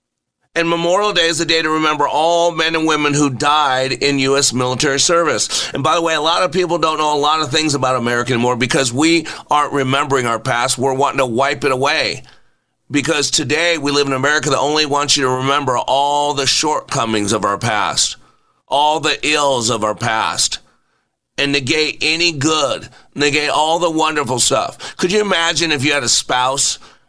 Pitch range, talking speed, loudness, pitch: 130-155 Hz, 195 wpm, -15 LUFS, 145 Hz